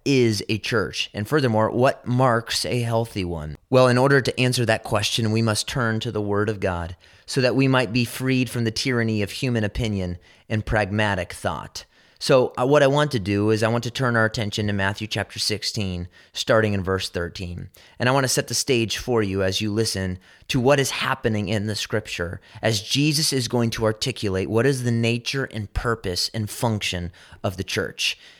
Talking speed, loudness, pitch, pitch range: 205 wpm, -22 LUFS, 110 Hz, 100-125 Hz